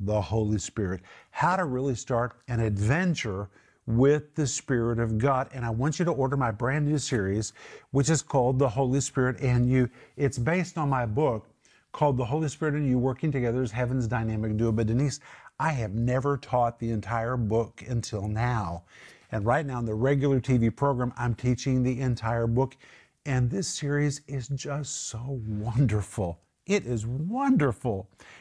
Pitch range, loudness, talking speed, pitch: 115-140 Hz, -27 LUFS, 175 wpm, 125 Hz